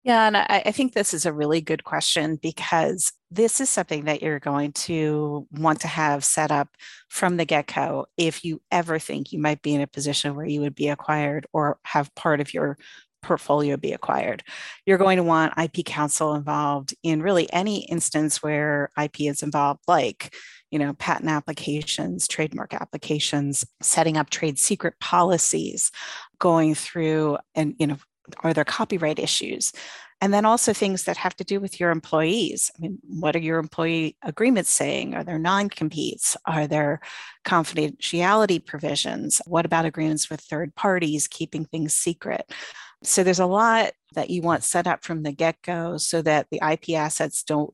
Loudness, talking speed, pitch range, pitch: -23 LUFS, 175 wpm, 150-175 Hz, 160 Hz